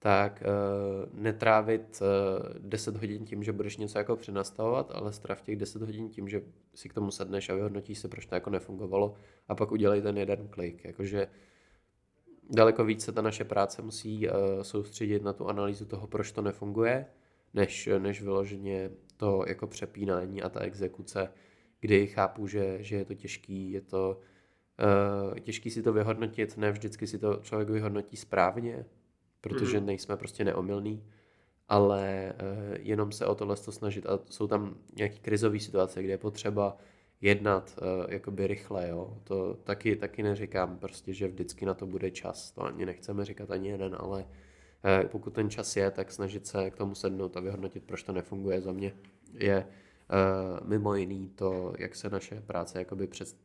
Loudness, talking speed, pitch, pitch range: -32 LUFS, 170 wpm, 100 Hz, 95-105 Hz